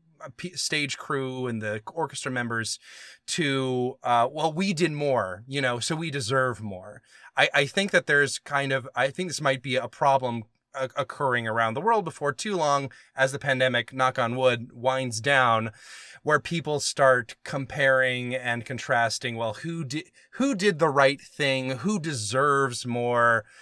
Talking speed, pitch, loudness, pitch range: 165 wpm, 135 Hz, -25 LUFS, 120-150 Hz